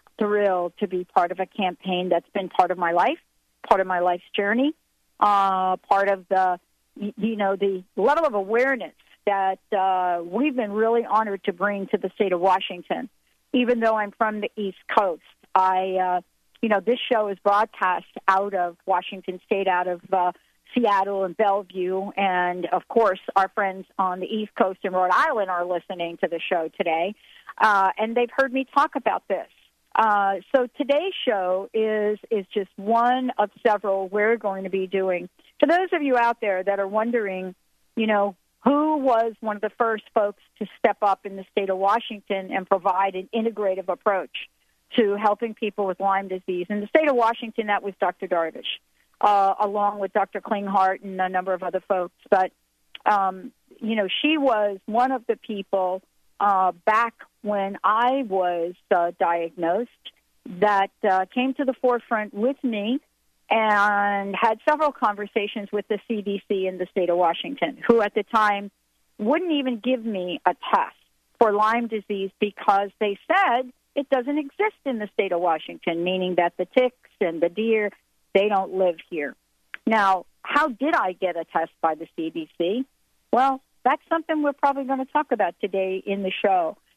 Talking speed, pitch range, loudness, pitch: 180 wpm, 185-230 Hz, -23 LUFS, 205 Hz